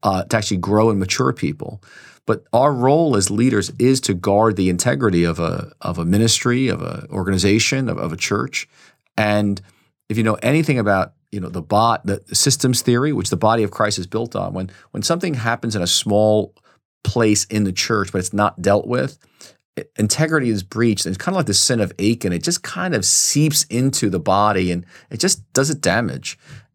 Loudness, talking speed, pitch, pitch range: -18 LUFS, 210 wpm, 105 Hz, 95-120 Hz